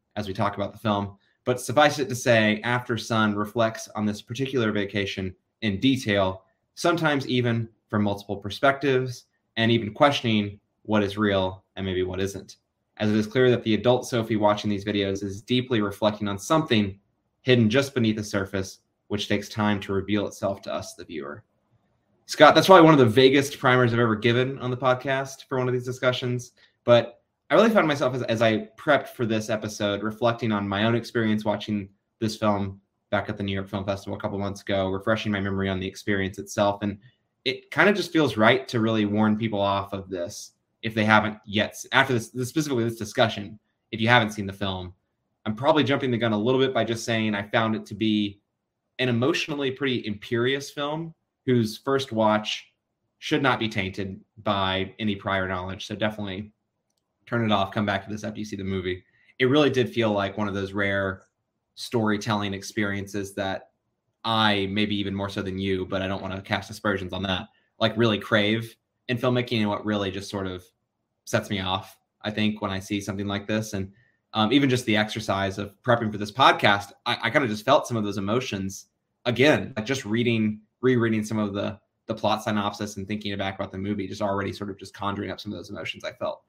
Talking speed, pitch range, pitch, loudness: 205 wpm, 100-120 Hz, 105 Hz, -24 LUFS